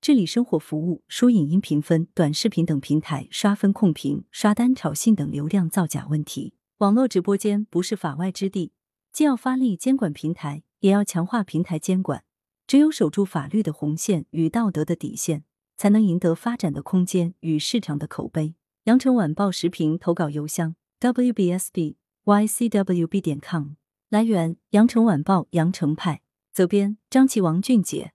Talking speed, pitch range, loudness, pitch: 270 characters per minute, 160-210 Hz, -22 LUFS, 180 Hz